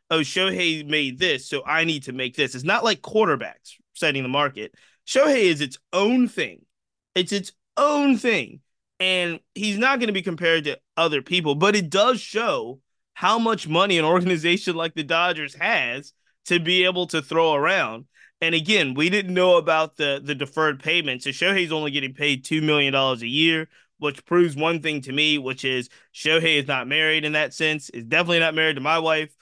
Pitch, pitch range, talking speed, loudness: 160 Hz, 145-180 Hz, 200 wpm, -21 LUFS